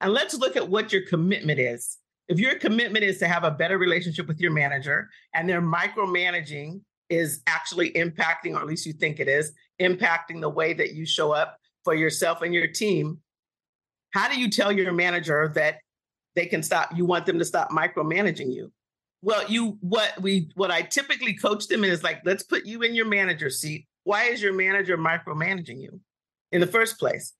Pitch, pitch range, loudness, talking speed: 175 Hz, 160-200 Hz, -24 LUFS, 195 wpm